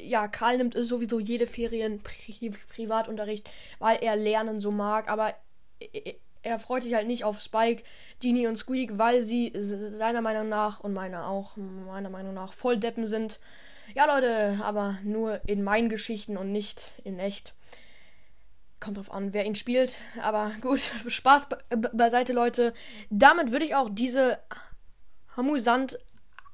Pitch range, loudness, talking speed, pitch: 210-245 Hz, -28 LUFS, 165 wpm, 225 Hz